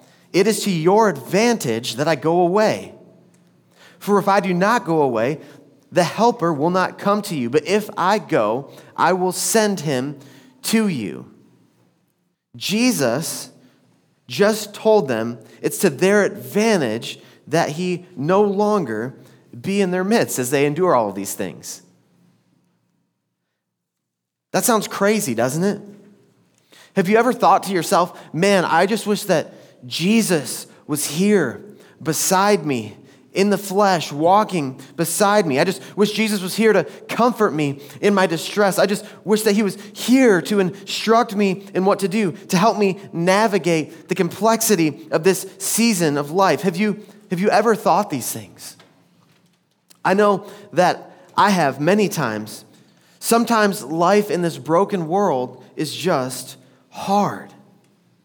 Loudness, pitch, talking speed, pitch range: -19 LUFS, 190 Hz, 150 wpm, 160-205 Hz